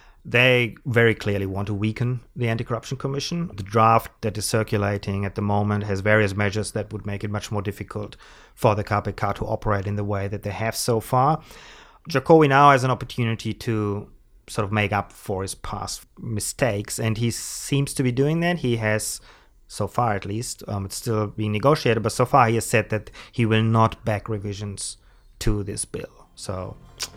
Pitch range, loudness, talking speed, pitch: 105-120 Hz, -23 LUFS, 200 wpm, 110 Hz